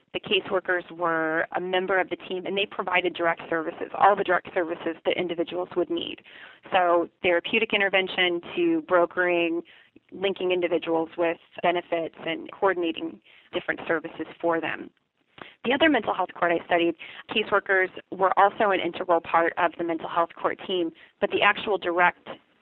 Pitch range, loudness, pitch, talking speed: 170-190 Hz, -25 LUFS, 175 Hz, 155 wpm